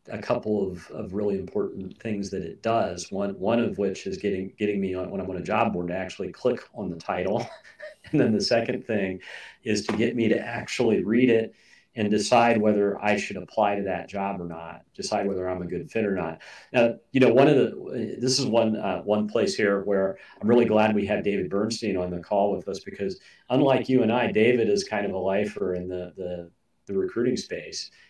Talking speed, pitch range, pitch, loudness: 225 wpm, 95-115 Hz, 105 Hz, -25 LUFS